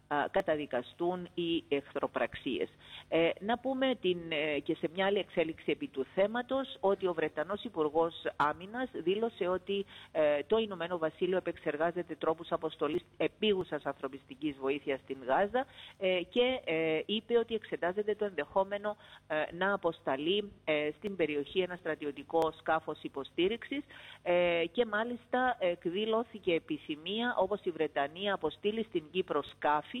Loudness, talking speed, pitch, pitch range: -34 LUFS, 130 wpm, 175 Hz, 155-210 Hz